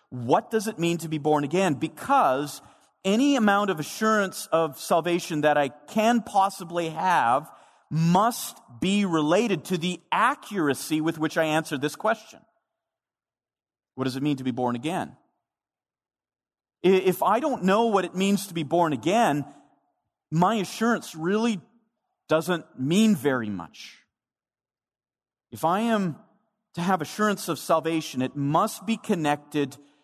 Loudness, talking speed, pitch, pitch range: -25 LUFS, 140 wpm, 170 Hz, 150-205 Hz